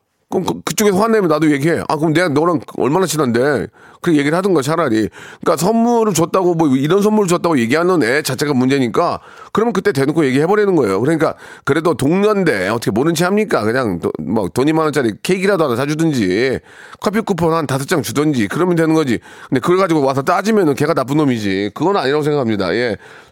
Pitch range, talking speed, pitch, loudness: 140-185 Hz, 455 characters per minute, 160 Hz, -15 LUFS